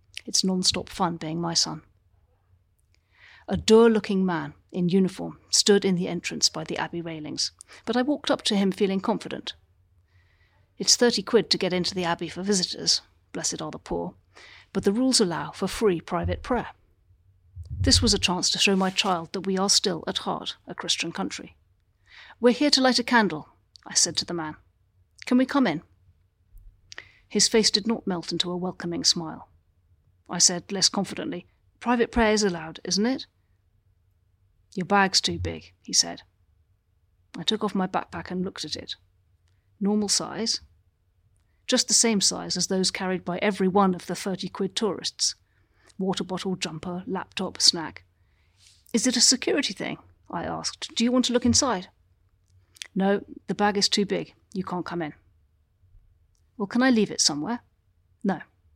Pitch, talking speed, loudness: 175 Hz, 170 wpm, -24 LUFS